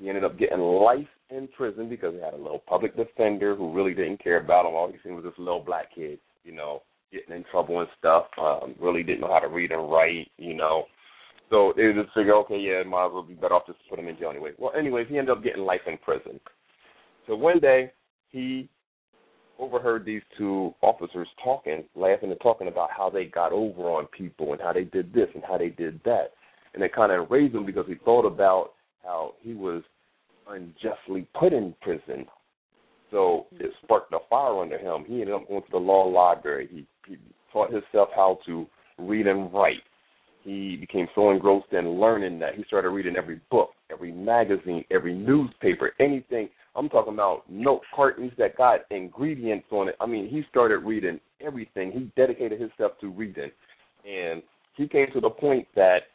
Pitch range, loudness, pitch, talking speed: 90-130 Hz, -25 LUFS, 100 Hz, 200 wpm